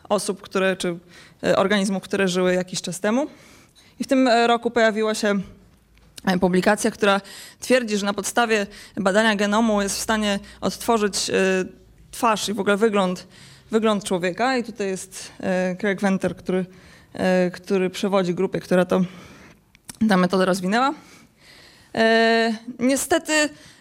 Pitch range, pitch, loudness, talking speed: 185-225 Hz, 200 Hz, -21 LUFS, 135 wpm